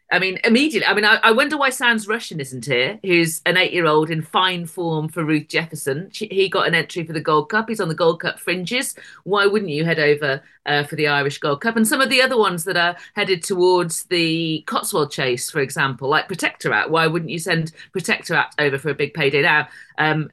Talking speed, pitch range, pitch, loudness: 230 wpm, 150-195 Hz, 170 Hz, -19 LUFS